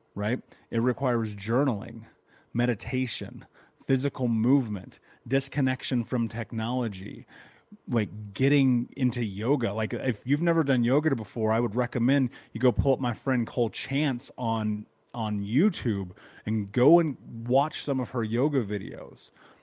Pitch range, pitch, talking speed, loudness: 110-135 Hz, 120 Hz, 135 wpm, -27 LUFS